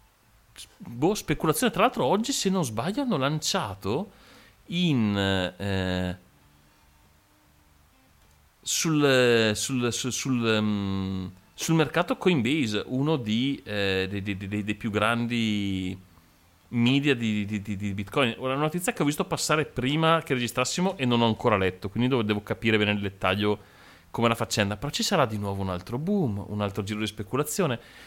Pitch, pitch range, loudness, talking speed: 110 Hz, 100-140 Hz, -26 LUFS, 155 wpm